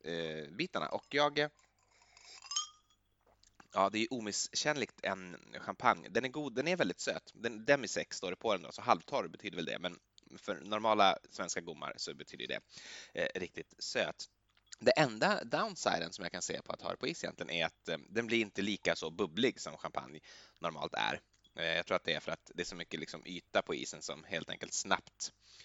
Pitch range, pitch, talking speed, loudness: 90-145 Hz, 110 Hz, 205 wpm, -36 LUFS